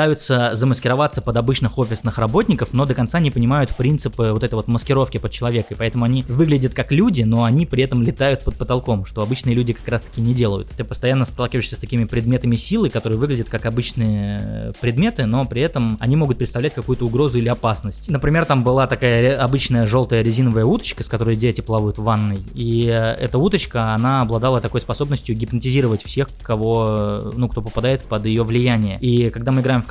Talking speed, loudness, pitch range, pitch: 195 wpm, -19 LUFS, 115-130 Hz, 120 Hz